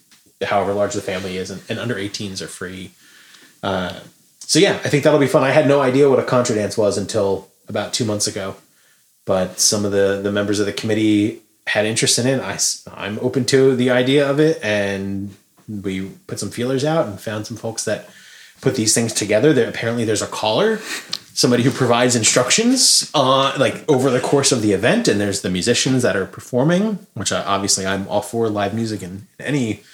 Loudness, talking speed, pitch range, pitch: -18 LUFS, 205 wpm, 100-135 Hz, 110 Hz